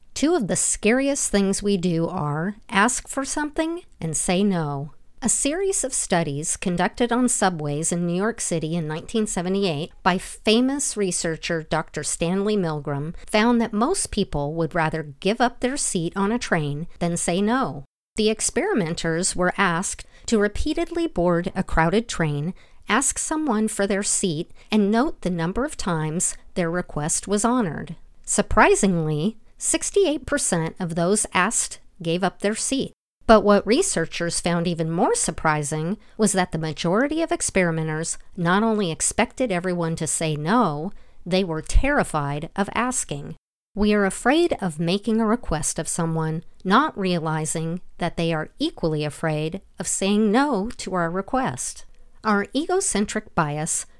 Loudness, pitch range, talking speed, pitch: -23 LUFS, 165-225 Hz, 150 wpm, 190 Hz